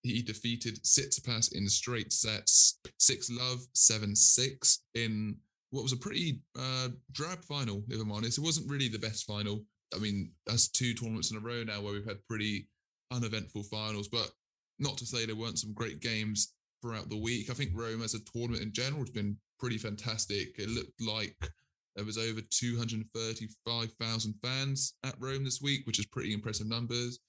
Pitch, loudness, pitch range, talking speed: 115 Hz, -30 LUFS, 105-125 Hz, 185 wpm